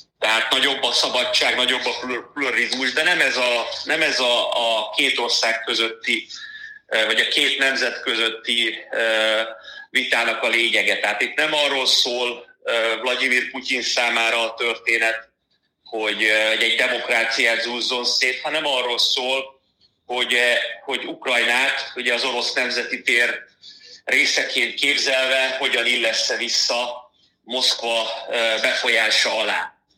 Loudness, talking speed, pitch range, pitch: -19 LUFS, 120 wpm, 115-135 Hz, 125 Hz